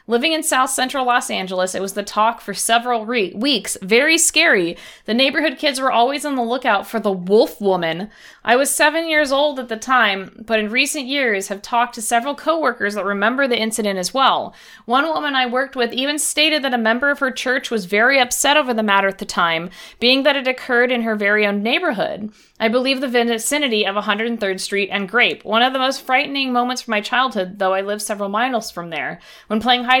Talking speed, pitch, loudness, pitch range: 220 wpm, 240 Hz, -17 LUFS, 210-265 Hz